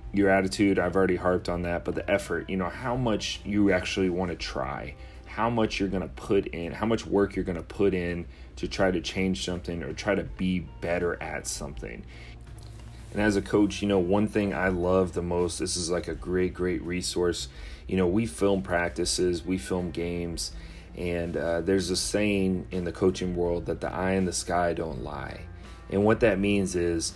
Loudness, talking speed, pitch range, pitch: -28 LUFS, 210 wpm, 85-100 Hz, 90 Hz